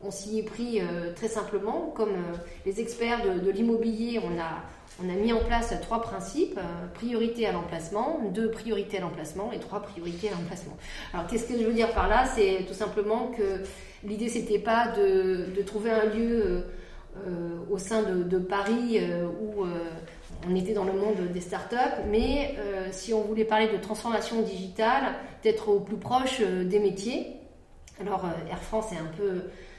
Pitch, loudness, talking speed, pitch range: 210 Hz, -29 LUFS, 195 wpm, 185-225 Hz